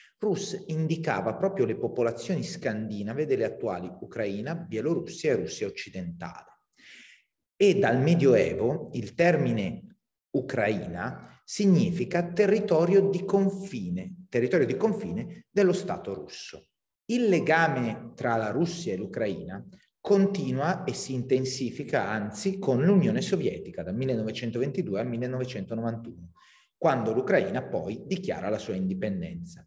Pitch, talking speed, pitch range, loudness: 170 Hz, 110 wpm, 125-195 Hz, -28 LUFS